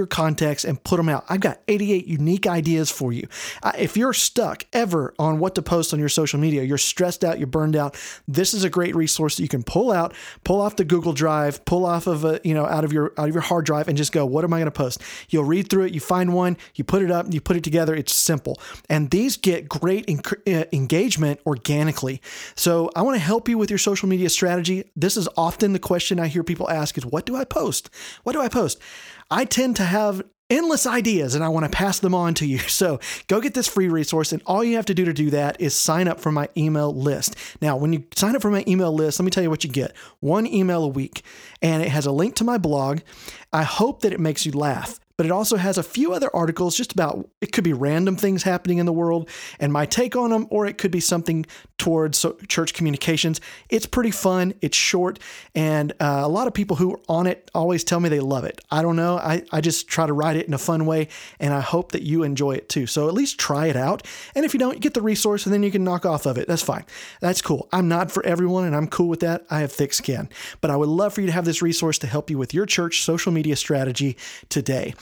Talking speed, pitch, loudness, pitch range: 260 wpm, 170 Hz, -22 LUFS, 155-190 Hz